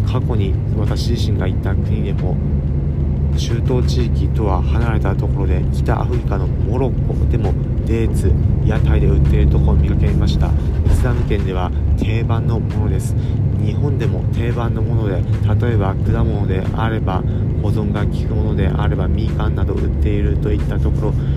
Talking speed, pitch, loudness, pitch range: 335 characters per minute, 95 Hz, -17 LUFS, 70-110 Hz